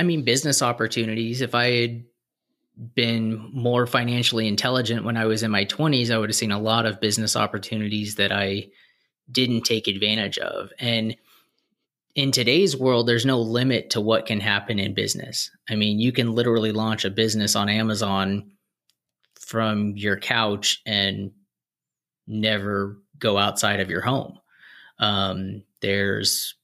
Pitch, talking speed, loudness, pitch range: 110 Hz, 150 wpm, -22 LUFS, 100-120 Hz